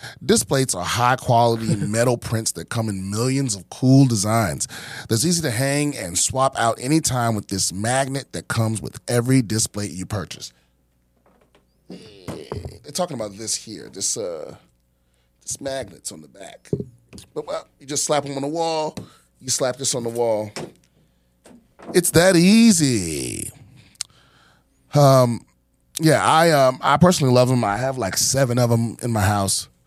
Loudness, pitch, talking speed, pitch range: -20 LUFS, 120 Hz, 155 wpm, 105-135 Hz